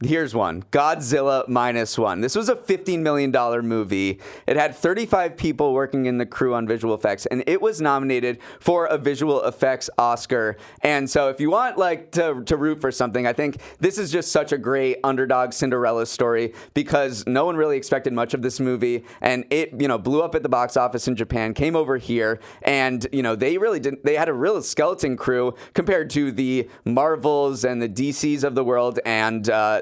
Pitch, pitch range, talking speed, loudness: 135 Hz, 120-150 Hz, 205 wpm, -22 LUFS